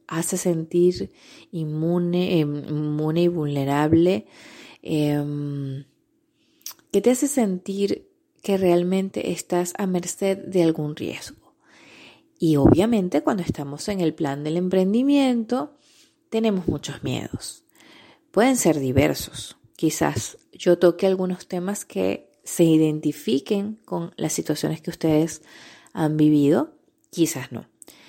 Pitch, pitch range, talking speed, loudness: 180 Hz, 155-225 Hz, 110 wpm, -23 LUFS